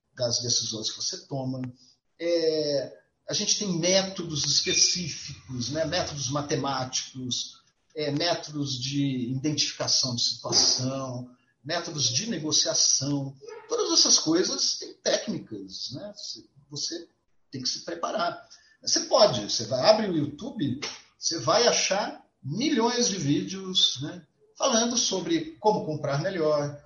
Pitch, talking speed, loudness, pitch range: 155 Hz, 120 wpm, -25 LUFS, 135-190 Hz